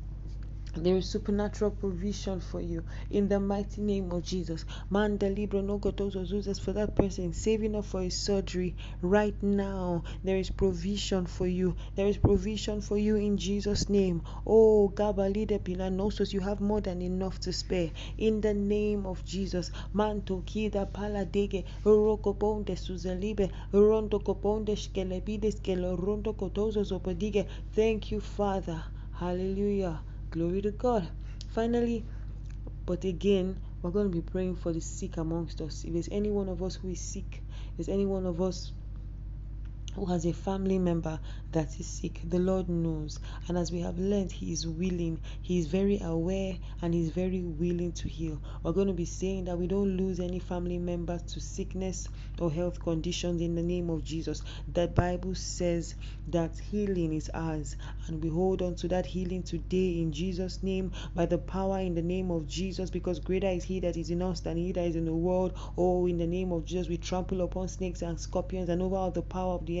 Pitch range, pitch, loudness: 170-200 Hz, 185 Hz, -31 LUFS